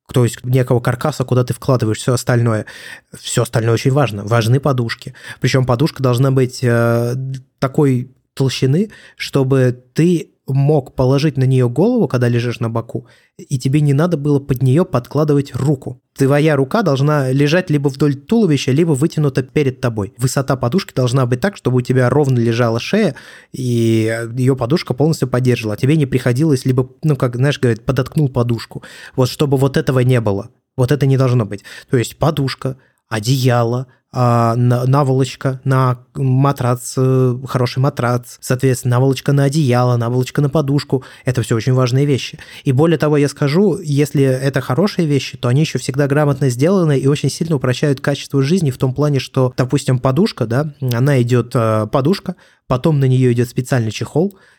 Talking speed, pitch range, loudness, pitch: 165 wpm, 125-145 Hz, -16 LUFS, 135 Hz